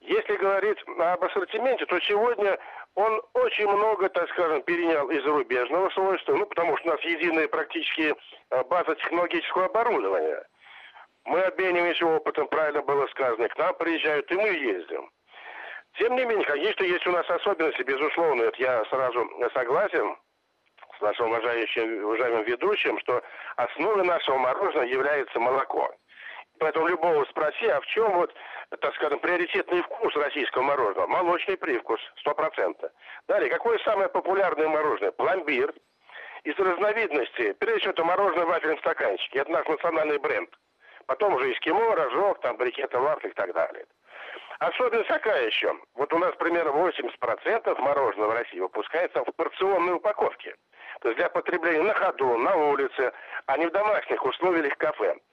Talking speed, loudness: 145 wpm, -26 LUFS